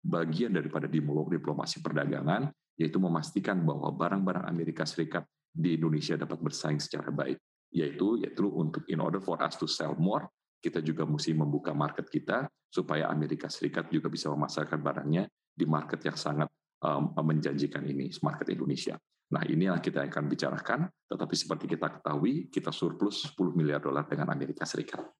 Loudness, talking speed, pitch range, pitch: -32 LUFS, 155 wpm, 75-80 Hz, 80 Hz